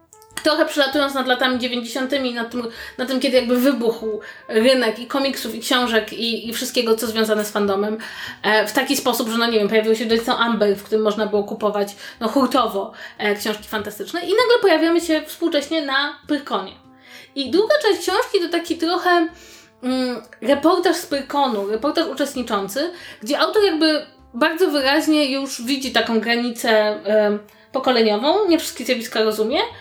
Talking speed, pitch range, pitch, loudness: 165 wpm, 225-310 Hz, 255 Hz, -19 LUFS